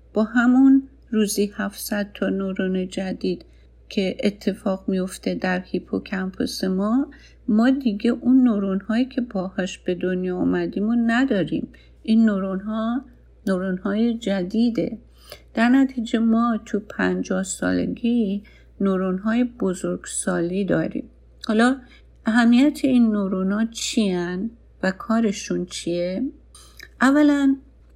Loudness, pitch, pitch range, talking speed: -22 LUFS, 210 Hz, 190-235 Hz, 115 wpm